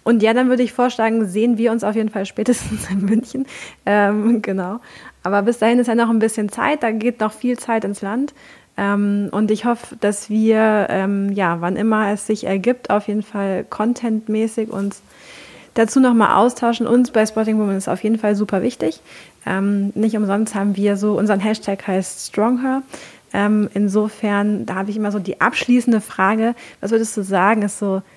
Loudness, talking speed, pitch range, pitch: -18 LUFS, 190 wpm, 200-230 Hz, 215 Hz